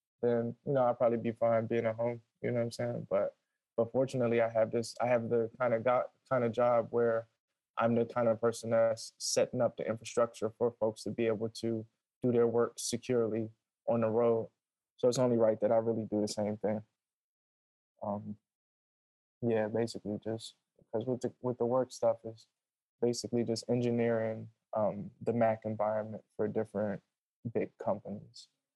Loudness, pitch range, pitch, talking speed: -33 LUFS, 110-120 Hz, 115 Hz, 185 wpm